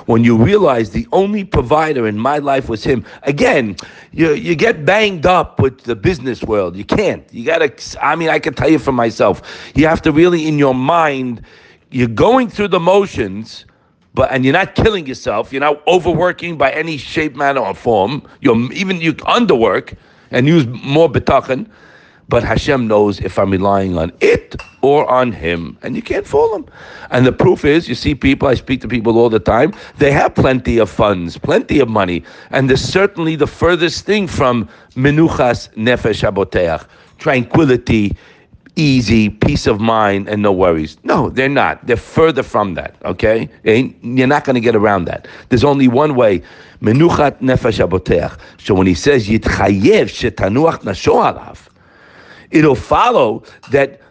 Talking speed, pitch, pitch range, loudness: 165 wpm, 130 Hz, 115-155 Hz, -14 LUFS